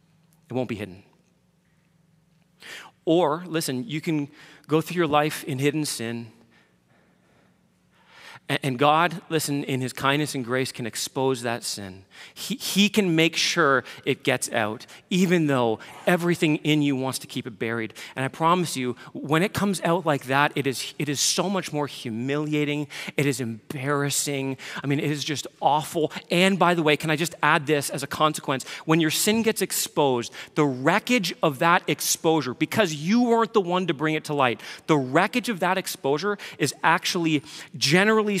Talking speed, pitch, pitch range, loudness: 175 wpm, 155 Hz, 135-170 Hz, -24 LUFS